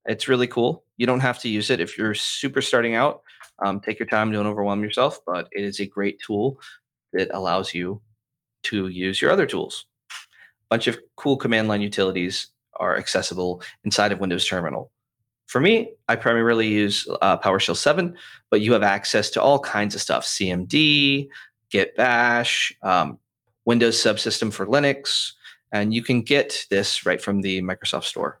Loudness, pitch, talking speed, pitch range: -22 LUFS, 110 Hz, 175 wpm, 100-125 Hz